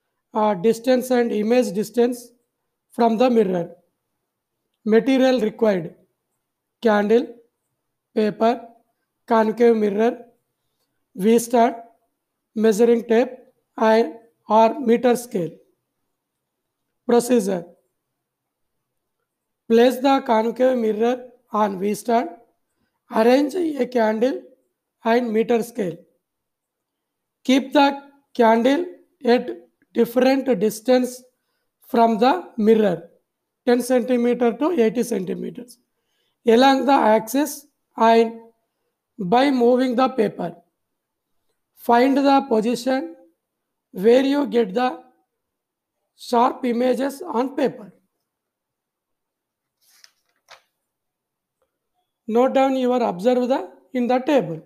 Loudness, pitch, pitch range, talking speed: -19 LUFS, 235 Hz, 225-255 Hz, 75 wpm